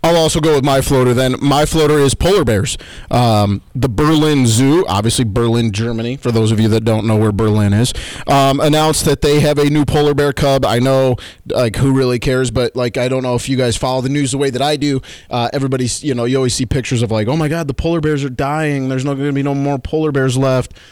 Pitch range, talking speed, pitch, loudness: 120-145 Hz, 255 wpm, 135 Hz, -14 LUFS